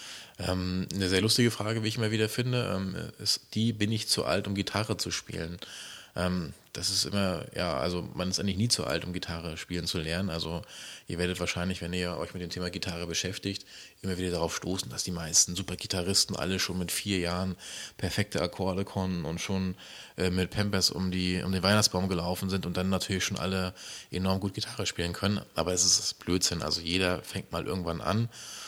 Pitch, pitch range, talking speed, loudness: 95 Hz, 90-100 Hz, 200 wpm, -30 LUFS